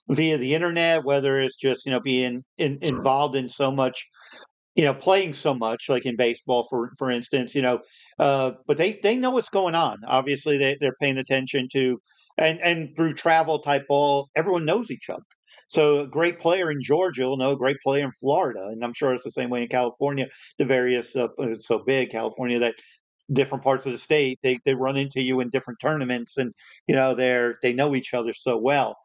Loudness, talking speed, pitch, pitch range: -24 LUFS, 215 wpm, 135 Hz, 125-150 Hz